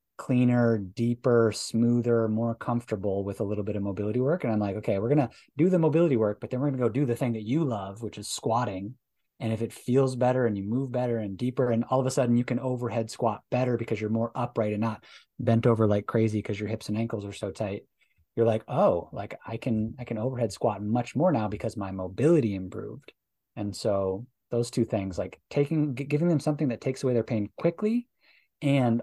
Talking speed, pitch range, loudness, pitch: 230 wpm, 110-130 Hz, -28 LUFS, 115 Hz